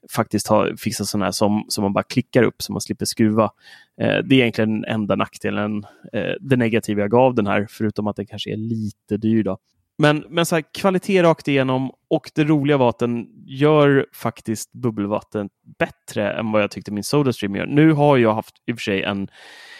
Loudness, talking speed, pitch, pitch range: -20 LUFS, 210 wpm, 110 Hz, 105-140 Hz